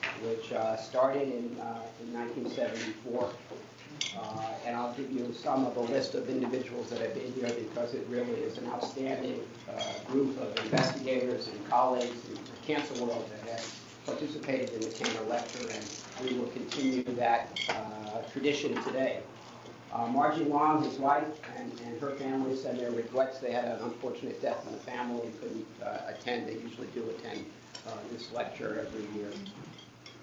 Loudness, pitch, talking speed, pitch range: -34 LUFS, 125 Hz, 170 wpm, 115-135 Hz